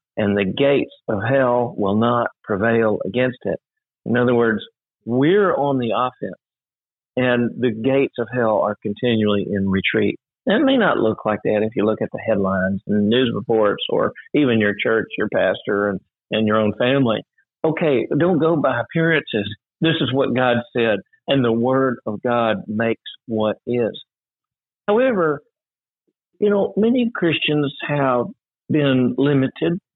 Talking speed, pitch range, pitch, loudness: 160 wpm, 110-140 Hz, 120 Hz, -19 LUFS